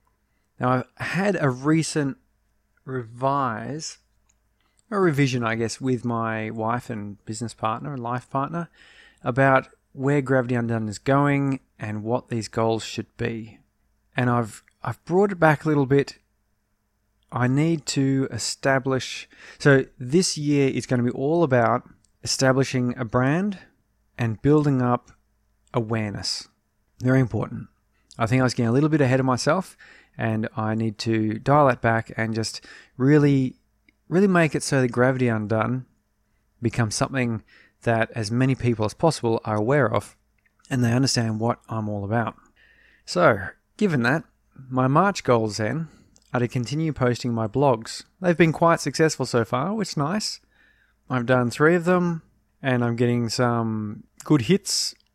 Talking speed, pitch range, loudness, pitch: 155 wpm, 110-140 Hz, -23 LUFS, 125 Hz